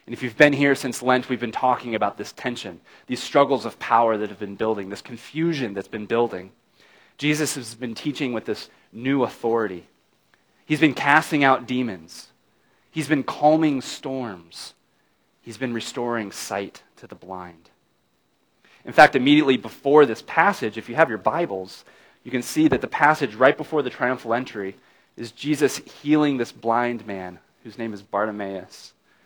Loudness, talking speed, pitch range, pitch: -22 LUFS, 170 wpm, 110-145 Hz, 120 Hz